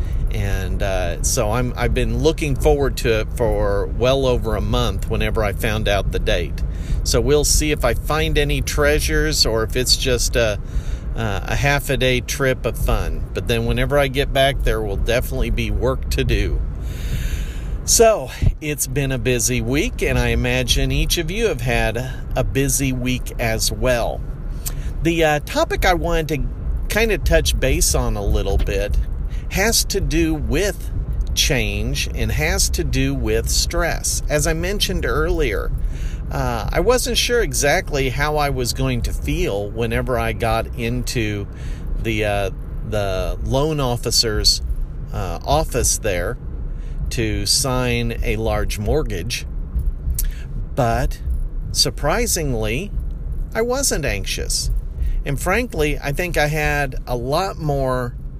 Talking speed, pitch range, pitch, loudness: 150 wpm, 105-140 Hz, 125 Hz, -20 LUFS